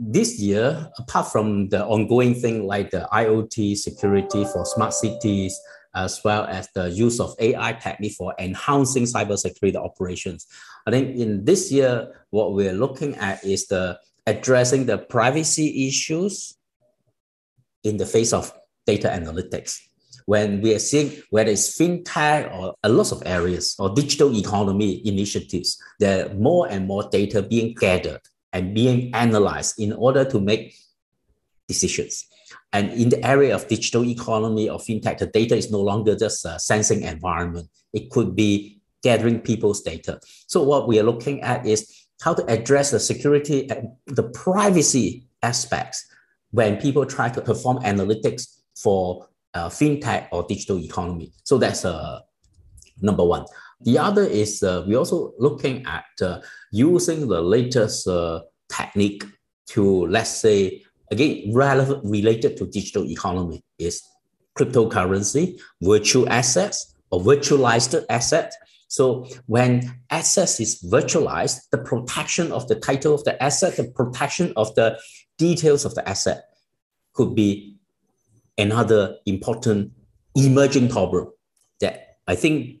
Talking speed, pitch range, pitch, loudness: 140 wpm, 100-135 Hz, 110 Hz, -21 LUFS